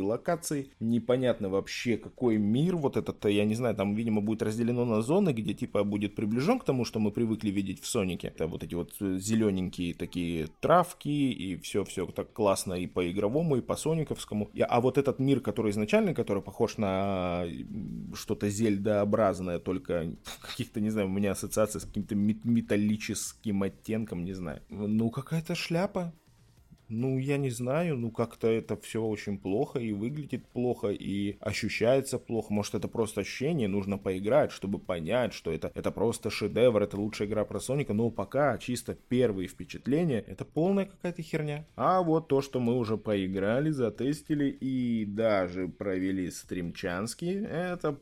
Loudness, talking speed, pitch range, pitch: -30 LUFS, 160 wpm, 100-130 Hz, 110 Hz